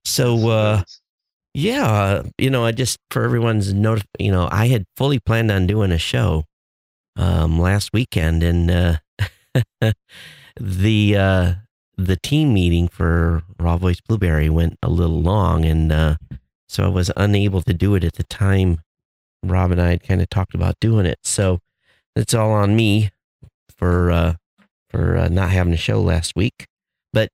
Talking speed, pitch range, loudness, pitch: 170 wpm, 85-110 Hz, -19 LUFS, 95 Hz